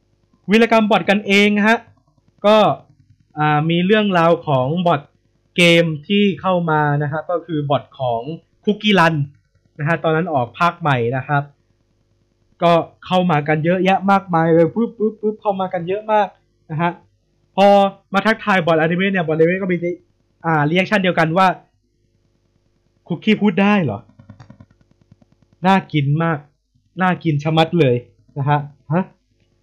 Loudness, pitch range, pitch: -17 LUFS, 125-185 Hz, 160 Hz